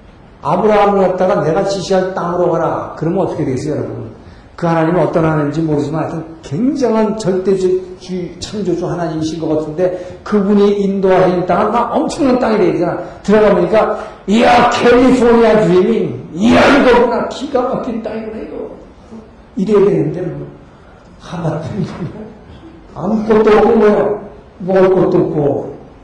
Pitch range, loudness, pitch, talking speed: 175-215 Hz, -13 LUFS, 190 Hz, 325 characters per minute